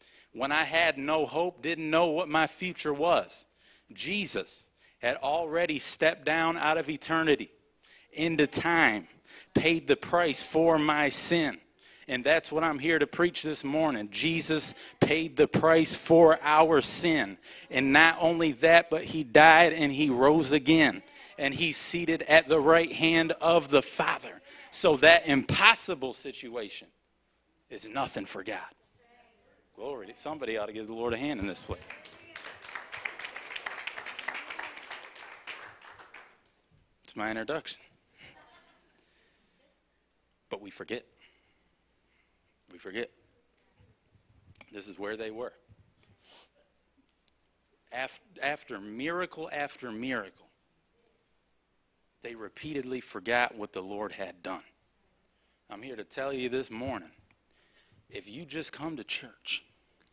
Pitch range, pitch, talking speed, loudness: 140-165 Hz, 155 Hz, 120 wpm, -27 LUFS